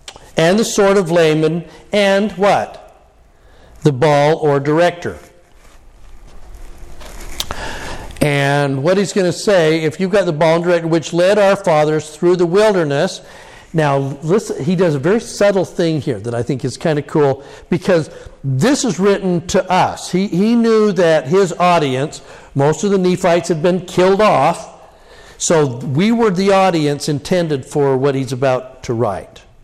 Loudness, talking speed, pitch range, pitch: -15 LUFS, 160 wpm, 145-190 Hz, 170 Hz